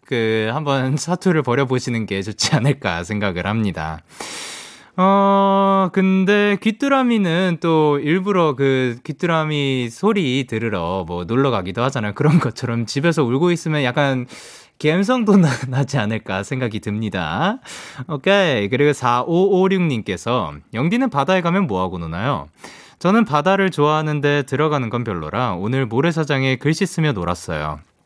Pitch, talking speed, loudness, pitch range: 140 Hz, 300 characters per minute, -18 LUFS, 110-175 Hz